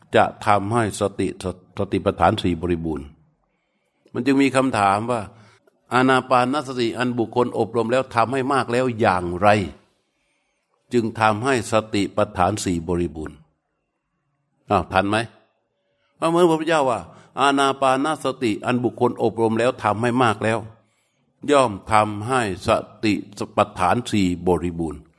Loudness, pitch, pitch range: -21 LUFS, 115 Hz, 100-125 Hz